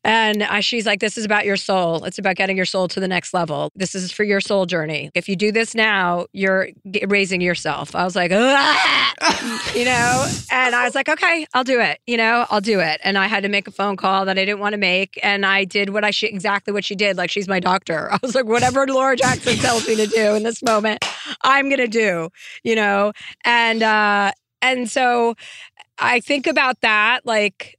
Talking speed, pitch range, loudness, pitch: 225 wpm, 195-235 Hz, -18 LUFS, 210 Hz